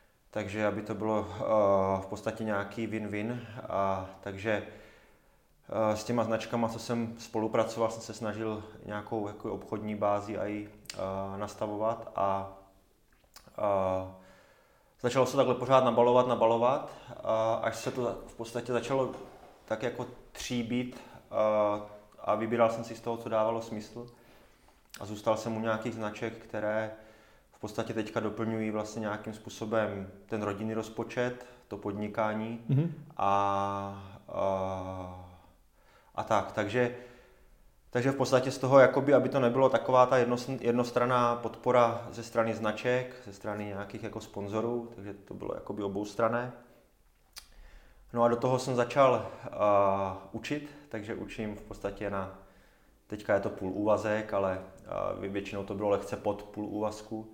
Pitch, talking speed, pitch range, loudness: 110 Hz, 140 wpm, 105-120 Hz, -31 LUFS